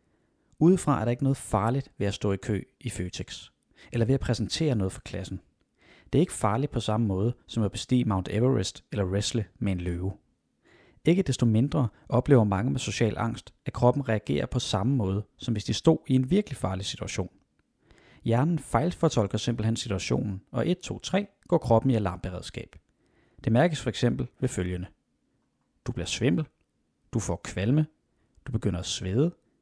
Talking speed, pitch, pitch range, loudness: 180 wpm, 115 Hz, 100-135 Hz, -28 LUFS